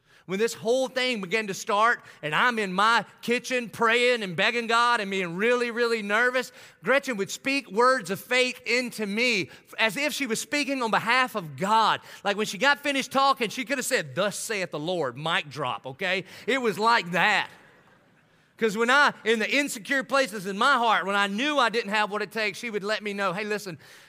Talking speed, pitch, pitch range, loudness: 210 wpm, 225 Hz, 200-250 Hz, -25 LUFS